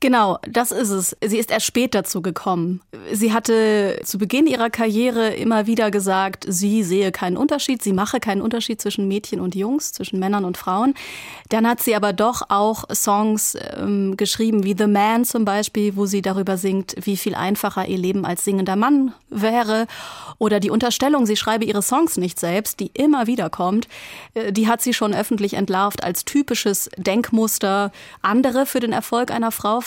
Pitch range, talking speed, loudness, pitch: 195-235 Hz, 180 wpm, -20 LUFS, 215 Hz